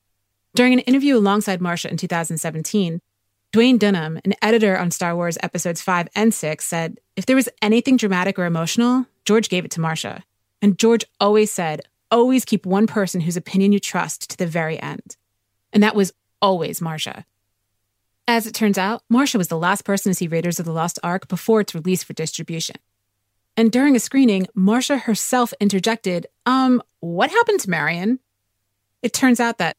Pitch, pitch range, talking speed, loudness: 190 Hz, 165-225 Hz, 180 wpm, -19 LUFS